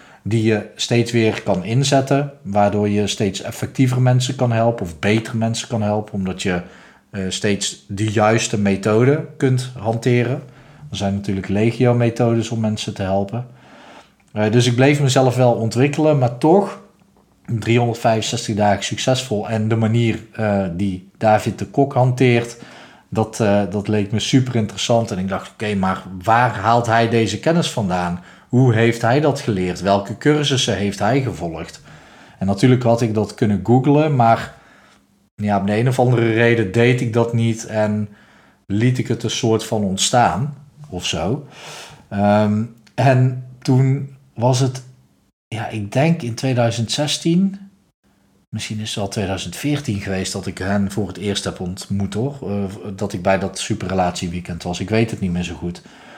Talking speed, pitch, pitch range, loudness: 165 wpm, 115 Hz, 100-125 Hz, -18 LUFS